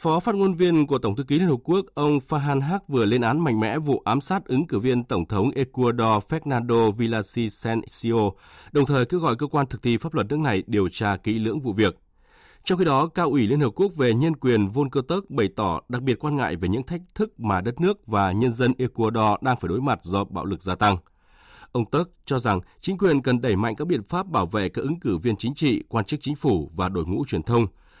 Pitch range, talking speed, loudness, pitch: 110-150 Hz, 250 wpm, -23 LUFS, 125 Hz